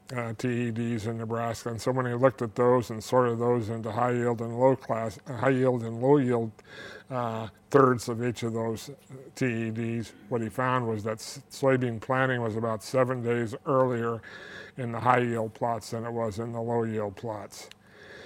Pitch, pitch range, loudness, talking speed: 120 Hz, 115-125 Hz, -28 LUFS, 185 wpm